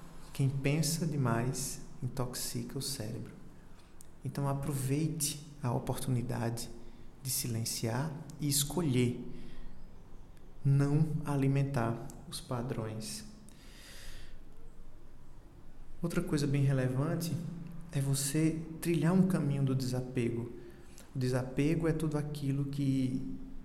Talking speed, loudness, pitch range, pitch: 90 wpm, -34 LUFS, 120-150 Hz, 135 Hz